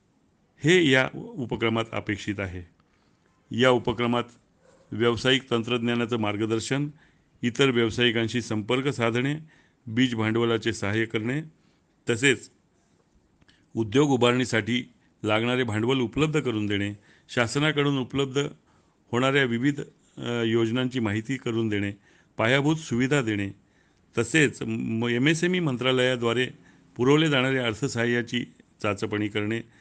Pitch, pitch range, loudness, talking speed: 120 Hz, 115-135 Hz, -25 LUFS, 95 wpm